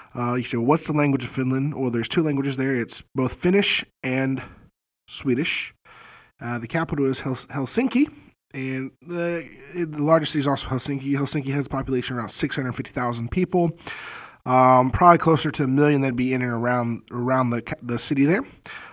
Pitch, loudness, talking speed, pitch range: 135 Hz, -22 LUFS, 180 wpm, 125-150 Hz